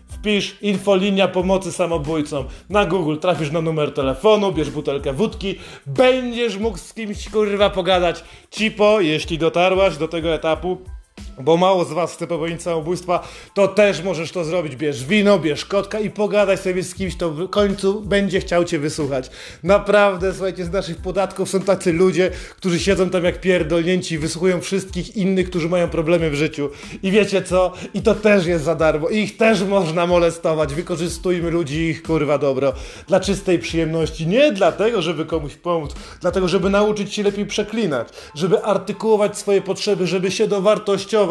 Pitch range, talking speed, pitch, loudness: 165-200 Hz, 165 wpm, 185 Hz, -19 LUFS